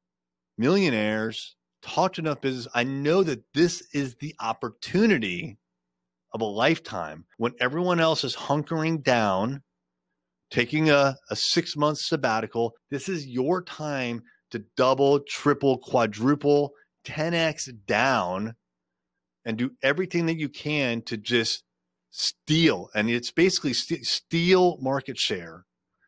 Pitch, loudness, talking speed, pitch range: 135 Hz, -25 LUFS, 120 wpm, 115-160 Hz